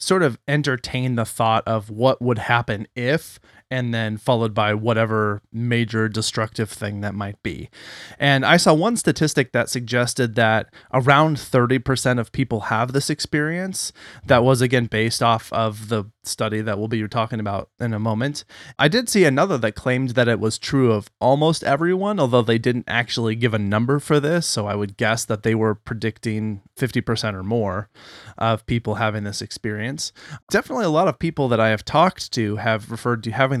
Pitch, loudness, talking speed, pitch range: 115 Hz, -21 LUFS, 185 wpm, 110-130 Hz